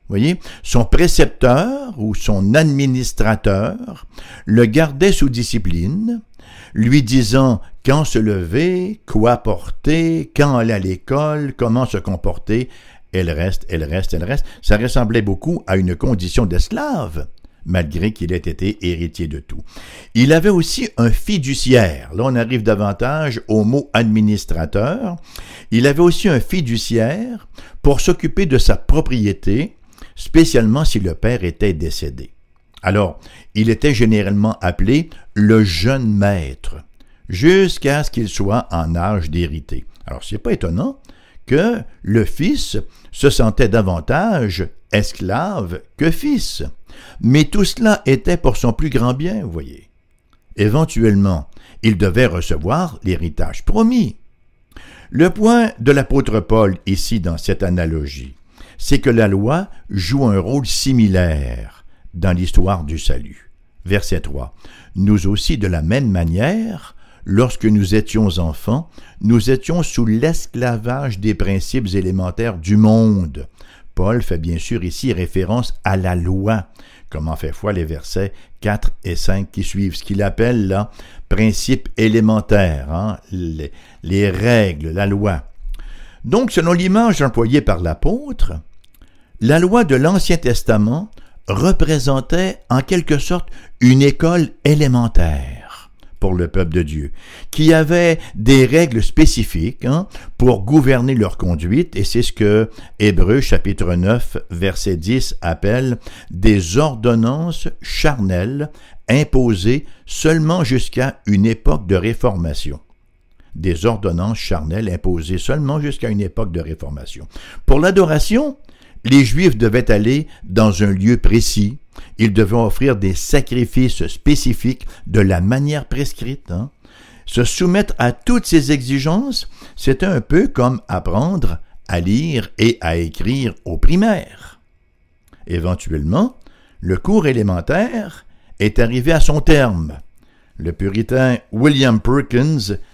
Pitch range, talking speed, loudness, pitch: 95-140 Hz, 130 wpm, -16 LUFS, 110 Hz